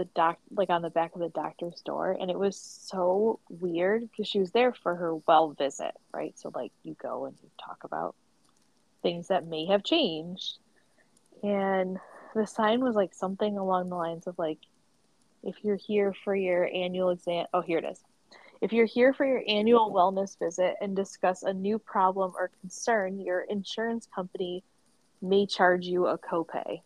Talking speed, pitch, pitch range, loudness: 185 wpm, 190 Hz, 180-210 Hz, -29 LUFS